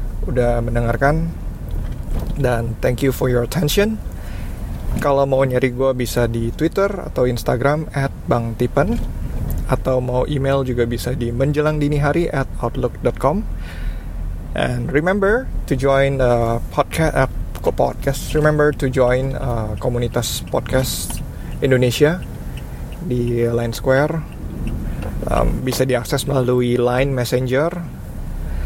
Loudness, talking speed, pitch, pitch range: -19 LUFS, 115 wpm, 125 Hz, 120-140 Hz